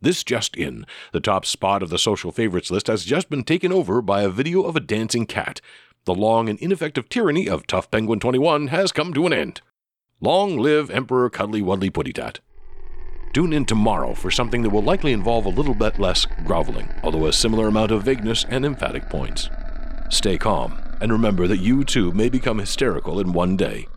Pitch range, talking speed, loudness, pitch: 105-140 Hz, 200 wpm, -21 LUFS, 115 Hz